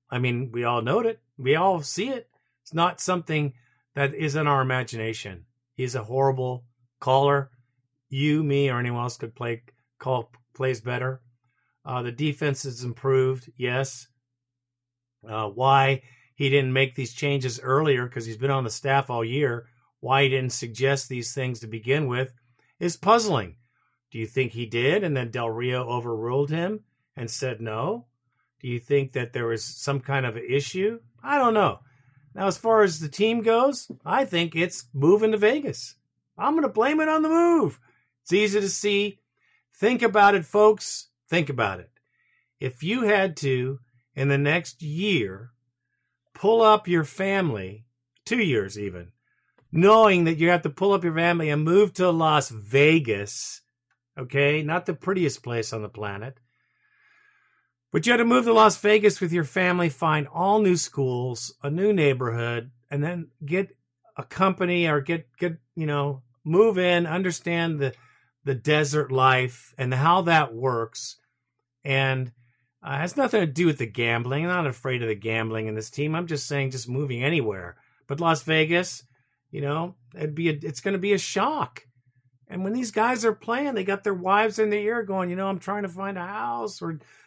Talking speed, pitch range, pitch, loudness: 180 wpm, 125-180 Hz, 140 Hz, -24 LUFS